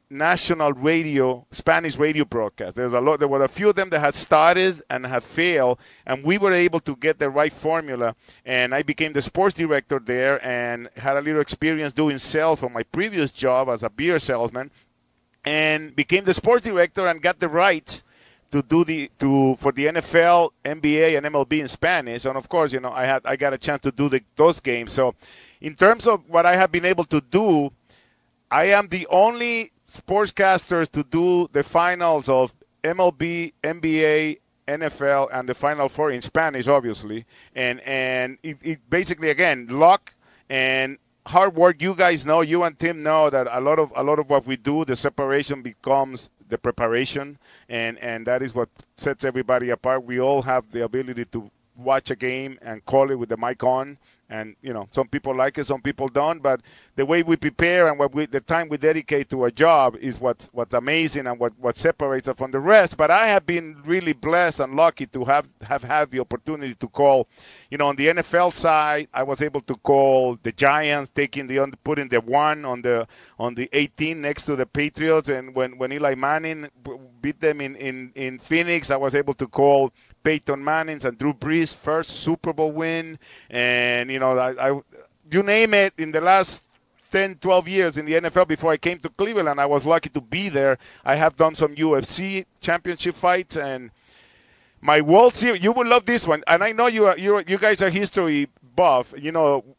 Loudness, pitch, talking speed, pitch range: -21 LUFS, 145 Hz, 205 wpm, 130-165 Hz